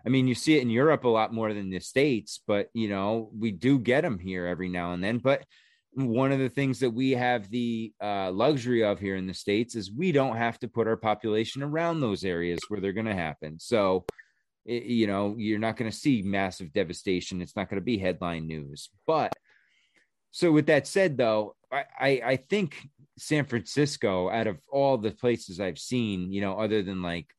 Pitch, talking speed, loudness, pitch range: 110 Hz, 215 wpm, -28 LUFS, 95-130 Hz